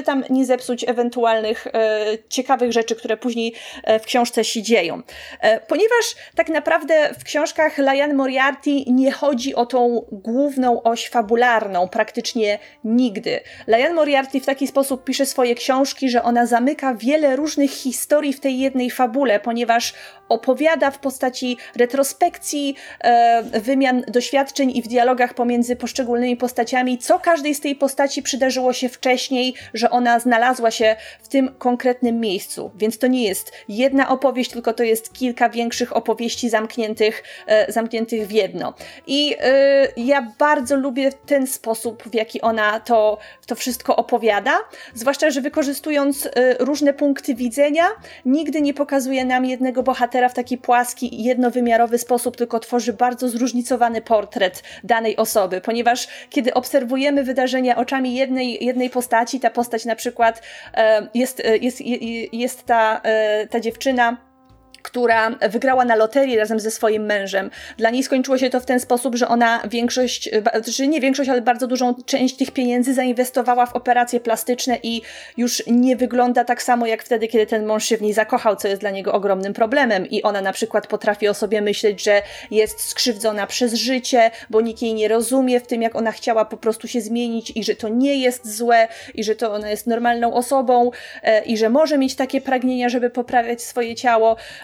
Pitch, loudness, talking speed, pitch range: 245 Hz, -19 LUFS, 165 wpm, 230-265 Hz